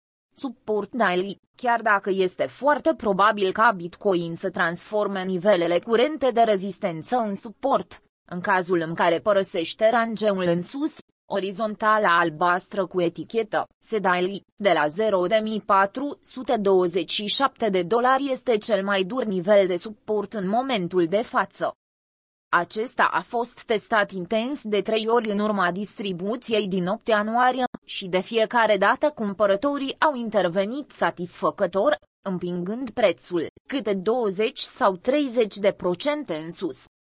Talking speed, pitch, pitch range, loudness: 130 wpm, 205 Hz, 185-235 Hz, -23 LUFS